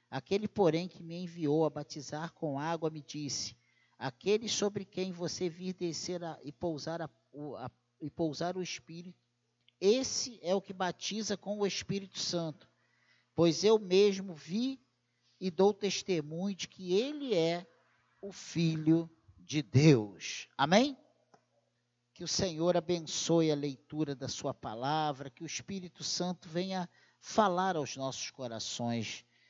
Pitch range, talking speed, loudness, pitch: 145-190 Hz, 140 wpm, -33 LUFS, 165 Hz